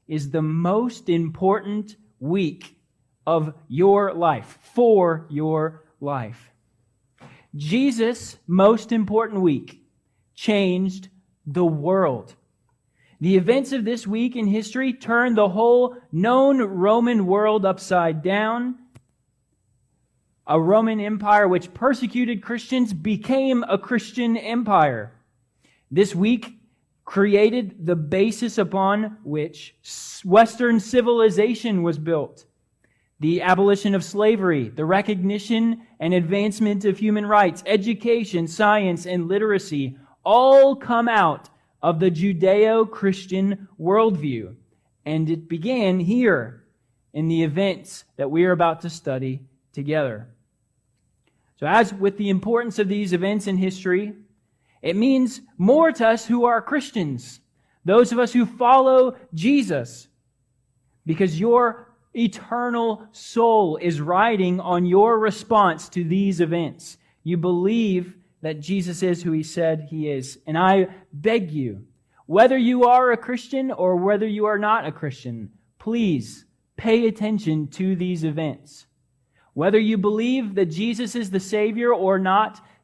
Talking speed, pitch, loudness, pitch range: 120 wpm, 195 Hz, -21 LUFS, 160-225 Hz